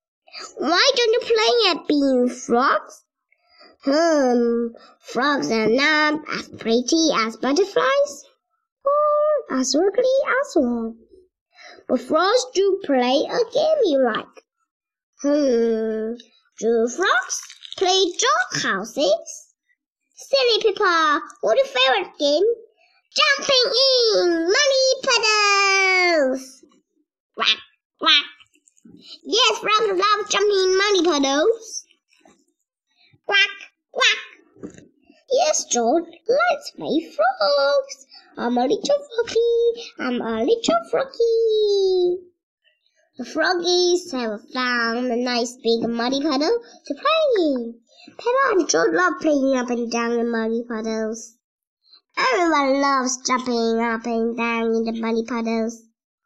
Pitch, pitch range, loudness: 310 Hz, 245-390 Hz, -19 LUFS